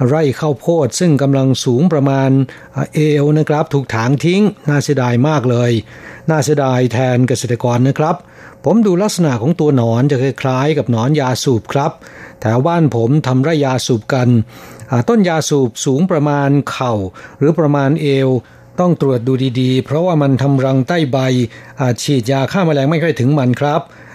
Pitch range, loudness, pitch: 125-155 Hz, -14 LUFS, 135 Hz